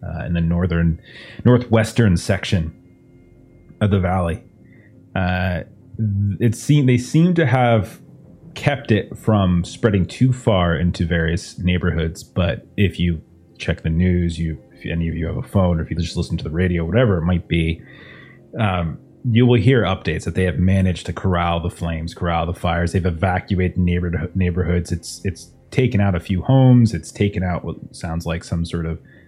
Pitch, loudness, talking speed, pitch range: 90 Hz, -19 LUFS, 175 wpm, 85-105 Hz